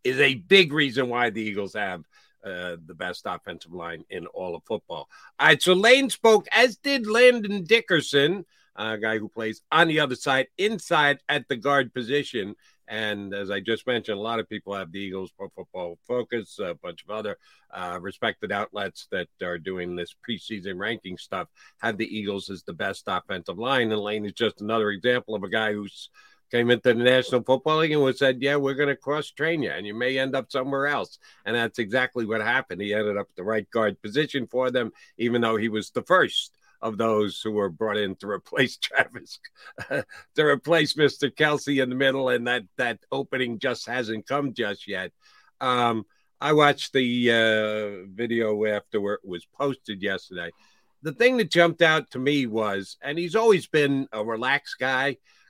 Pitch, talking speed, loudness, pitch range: 120 Hz, 195 wpm, -24 LUFS, 105-145 Hz